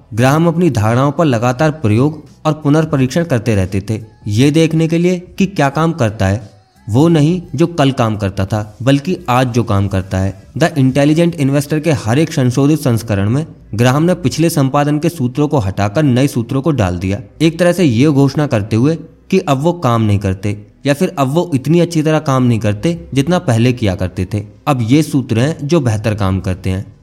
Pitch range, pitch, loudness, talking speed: 110-155 Hz, 135 Hz, -14 LUFS, 205 wpm